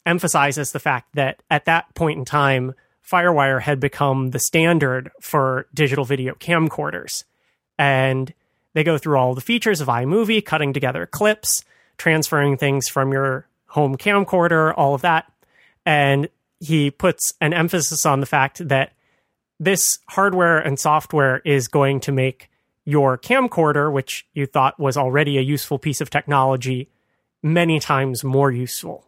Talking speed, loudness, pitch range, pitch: 150 wpm, -19 LUFS, 135-160 Hz, 145 Hz